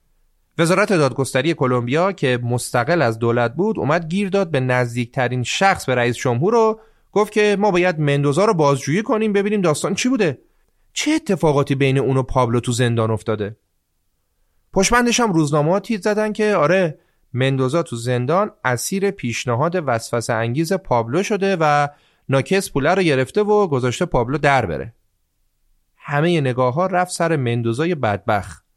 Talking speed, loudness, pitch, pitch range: 150 wpm, -18 LUFS, 145 Hz, 120-190 Hz